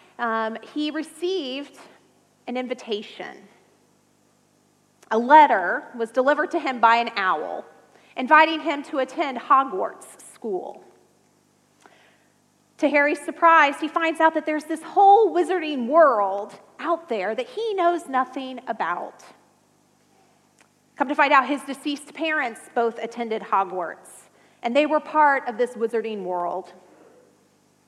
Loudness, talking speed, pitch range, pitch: -22 LUFS, 125 wpm, 230-315 Hz, 285 Hz